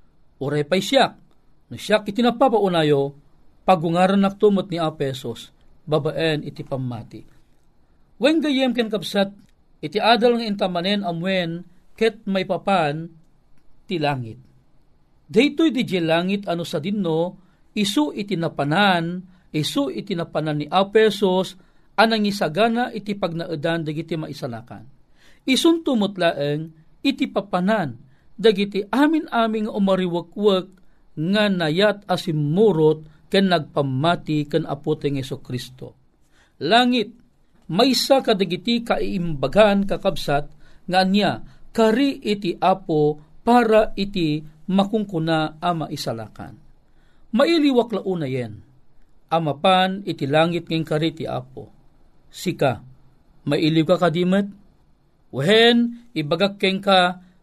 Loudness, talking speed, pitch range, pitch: -21 LUFS, 110 wpm, 155-210 Hz, 180 Hz